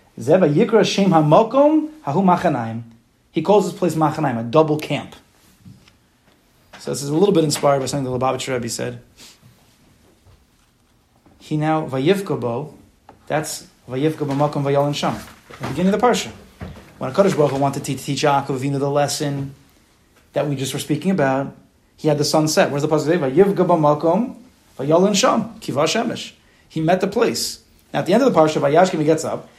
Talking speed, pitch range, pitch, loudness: 150 wpm, 140-175 Hz, 150 Hz, -19 LUFS